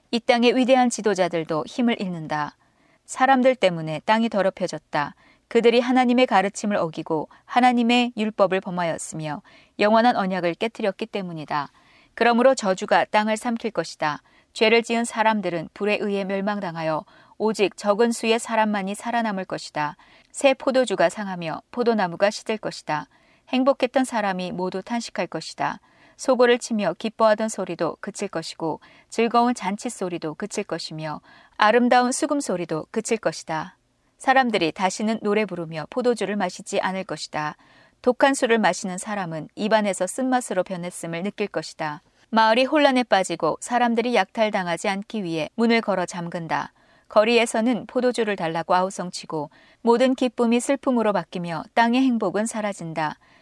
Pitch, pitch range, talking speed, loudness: 210 Hz, 180-235 Hz, 350 characters per minute, -23 LUFS